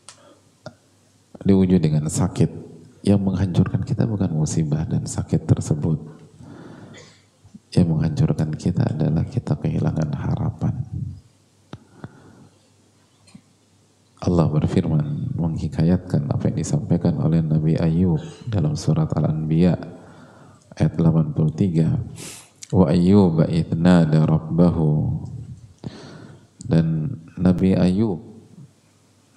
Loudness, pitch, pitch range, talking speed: -20 LUFS, 90 Hz, 80-120 Hz, 75 wpm